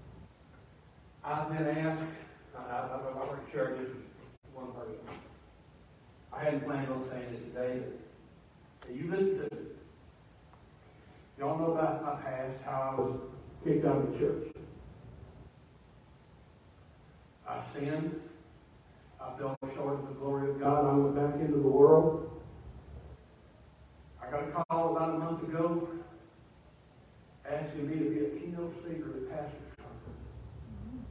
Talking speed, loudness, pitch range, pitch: 130 wpm, -33 LUFS, 125-155 Hz, 140 Hz